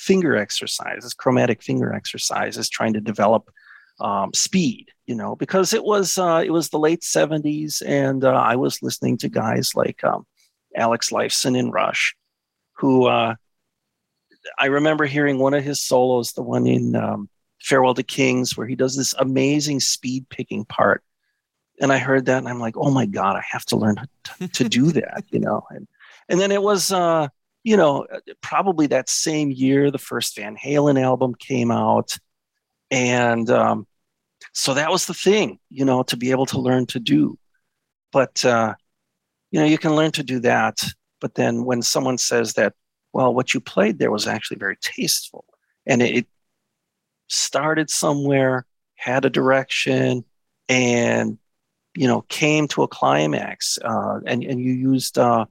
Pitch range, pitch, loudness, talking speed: 125-150 Hz, 130 Hz, -20 LUFS, 170 wpm